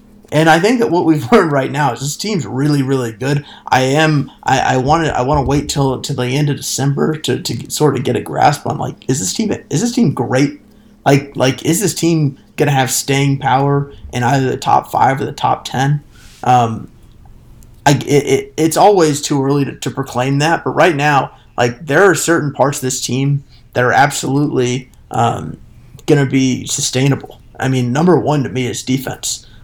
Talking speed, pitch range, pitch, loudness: 200 wpm, 125-150 Hz, 140 Hz, -15 LUFS